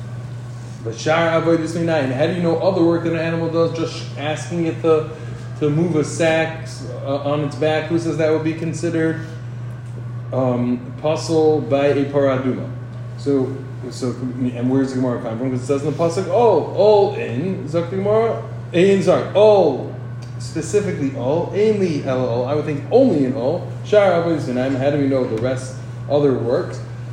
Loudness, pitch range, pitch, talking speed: -19 LUFS, 125-160 Hz, 140 Hz, 165 wpm